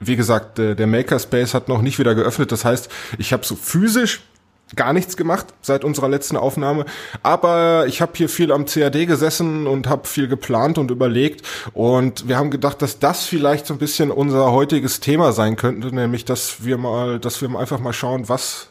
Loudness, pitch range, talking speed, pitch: -18 LUFS, 120-150 Hz, 195 wpm, 135 Hz